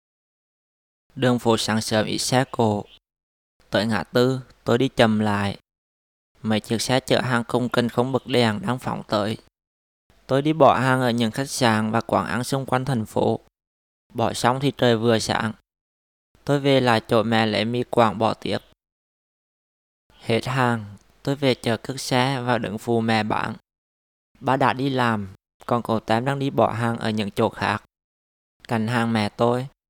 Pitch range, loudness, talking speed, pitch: 105-125 Hz, -22 LUFS, 180 wpm, 115 Hz